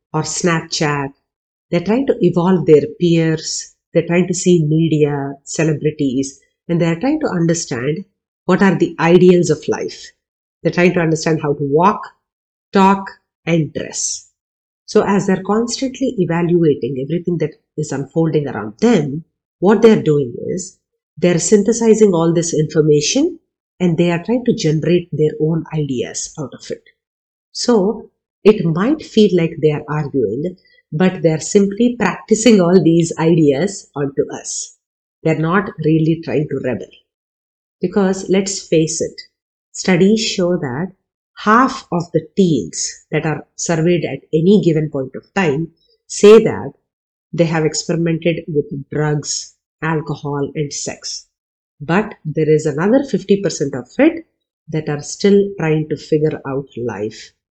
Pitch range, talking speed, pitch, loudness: 155-200 Hz, 145 wpm, 170 Hz, -16 LUFS